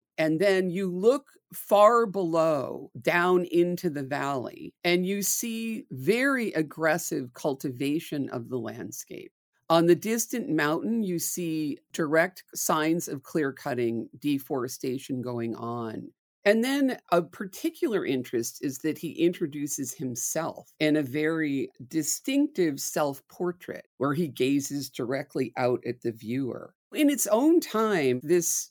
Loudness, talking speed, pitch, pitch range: -27 LUFS, 125 wpm, 160 Hz, 135-190 Hz